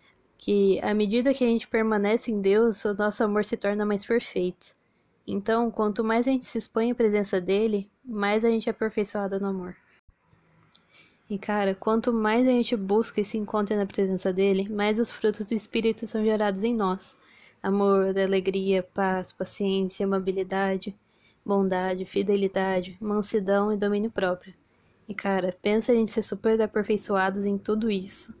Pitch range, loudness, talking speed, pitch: 195-225 Hz, -26 LUFS, 165 wpm, 210 Hz